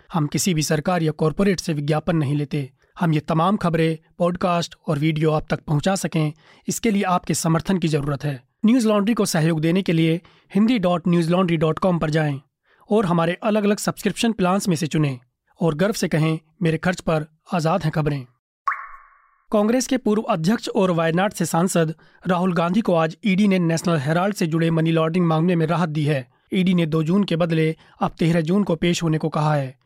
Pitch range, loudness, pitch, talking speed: 160-185 Hz, -21 LUFS, 170 Hz, 205 wpm